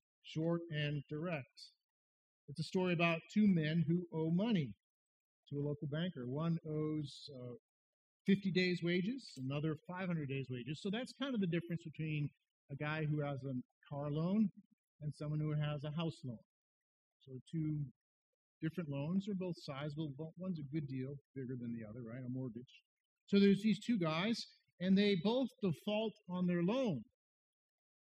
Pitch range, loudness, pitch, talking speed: 145-185 Hz, -39 LUFS, 160 Hz, 165 wpm